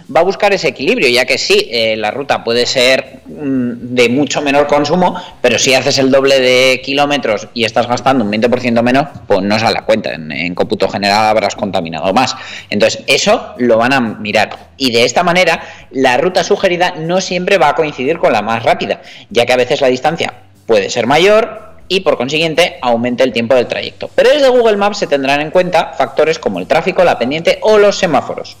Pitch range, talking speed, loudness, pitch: 125-185 Hz, 210 wpm, -12 LUFS, 140 Hz